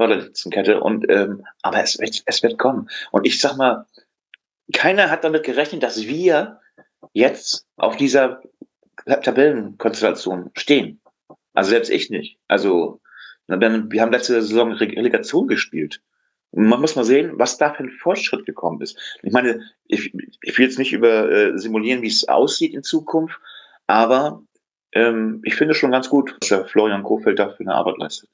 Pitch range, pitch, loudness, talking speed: 110-140 Hz, 120 Hz, -18 LUFS, 160 wpm